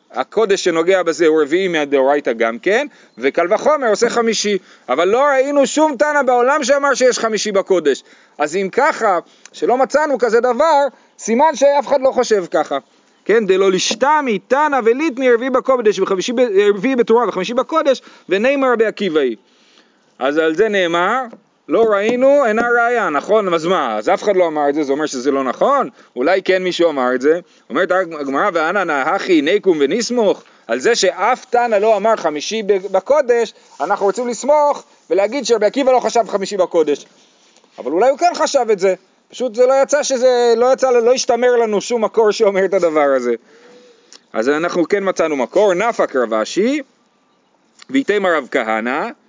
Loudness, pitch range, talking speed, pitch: -15 LUFS, 185-260 Hz, 165 wpm, 225 Hz